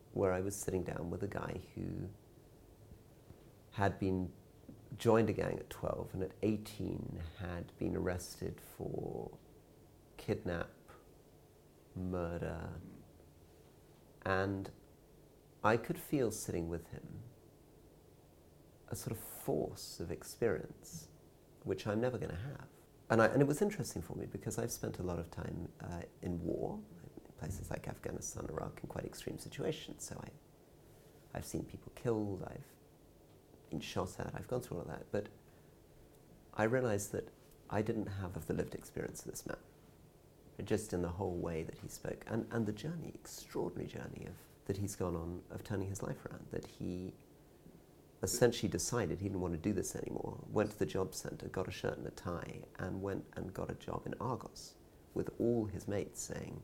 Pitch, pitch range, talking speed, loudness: 100 Hz, 90-115 Hz, 170 wpm, -40 LUFS